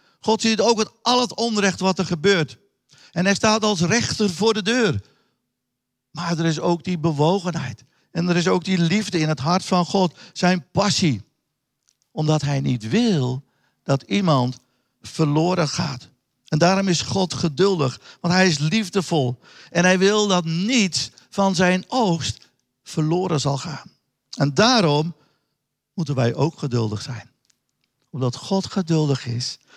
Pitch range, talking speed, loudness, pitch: 140-190 Hz, 155 wpm, -21 LUFS, 165 Hz